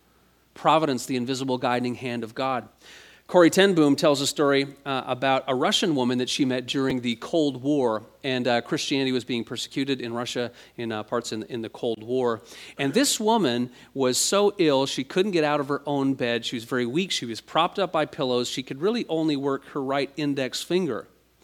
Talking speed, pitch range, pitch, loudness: 205 wpm, 125-150 Hz, 135 Hz, -25 LUFS